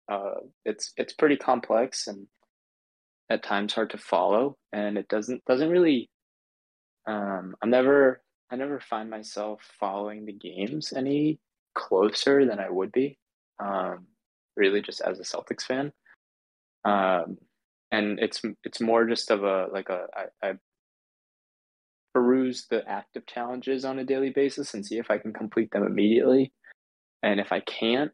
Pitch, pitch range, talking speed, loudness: 115 Hz, 105-135 Hz, 150 wpm, -27 LUFS